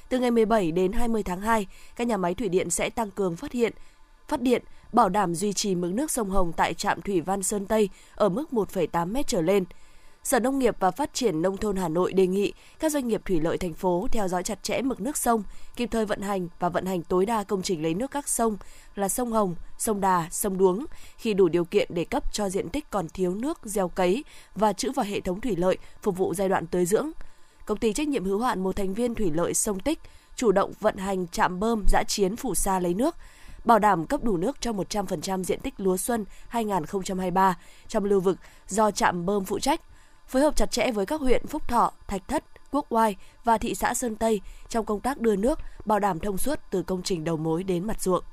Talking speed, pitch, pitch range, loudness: 240 wpm, 205 Hz, 185-235 Hz, -26 LUFS